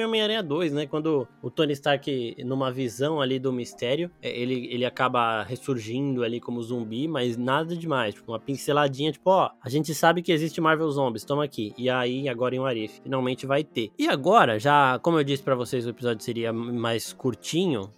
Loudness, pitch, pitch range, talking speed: -26 LUFS, 130 Hz, 120-150 Hz, 185 wpm